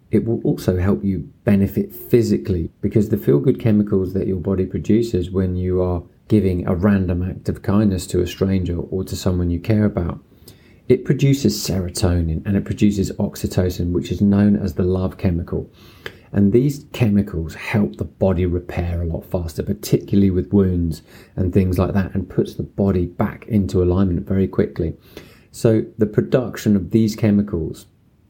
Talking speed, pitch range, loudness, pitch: 170 wpm, 90-105 Hz, -19 LUFS, 95 Hz